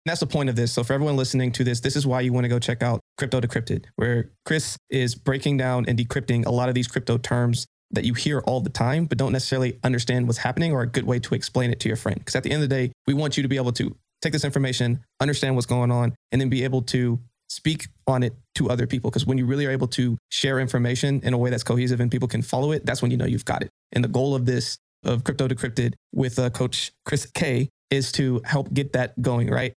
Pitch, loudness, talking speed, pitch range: 125 Hz, -24 LUFS, 275 wpm, 120-135 Hz